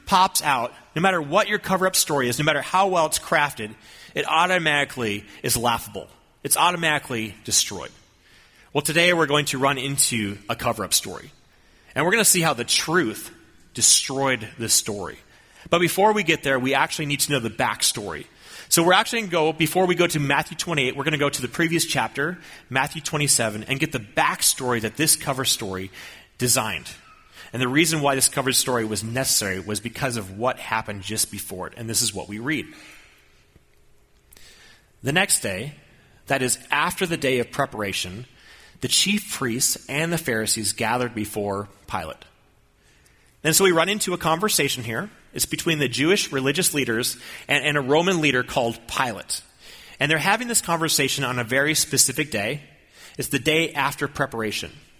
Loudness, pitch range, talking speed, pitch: -21 LUFS, 115-160 Hz, 180 wpm, 135 Hz